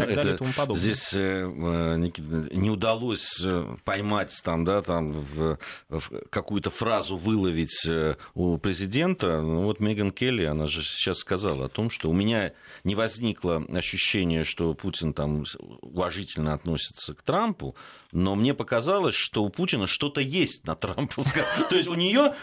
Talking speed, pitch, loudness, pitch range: 145 wpm, 95 Hz, -27 LUFS, 80-110 Hz